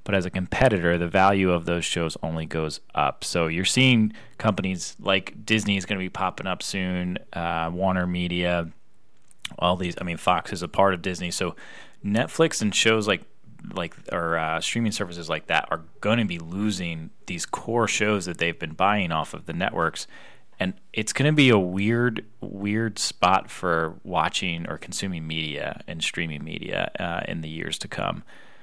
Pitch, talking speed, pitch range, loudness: 95 Hz, 185 wpm, 85-105 Hz, -25 LUFS